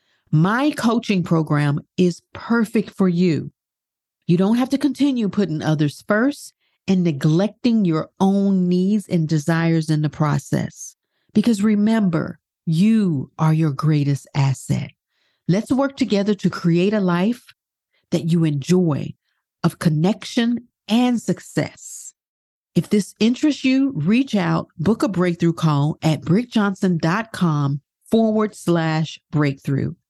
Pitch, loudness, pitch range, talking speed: 180 Hz, -20 LUFS, 160-215 Hz, 120 wpm